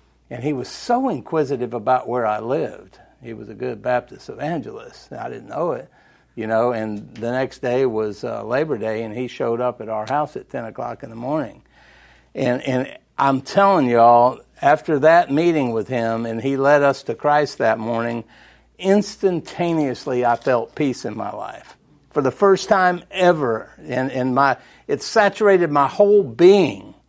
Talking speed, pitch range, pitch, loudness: 175 wpm, 120-160 Hz, 130 Hz, -19 LUFS